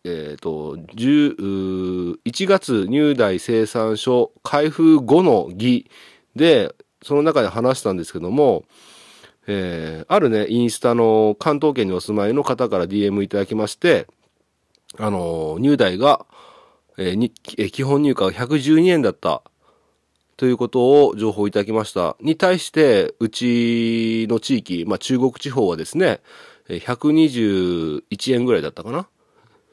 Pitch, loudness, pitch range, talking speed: 115 Hz, -19 LUFS, 100-145 Hz, 250 characters per minute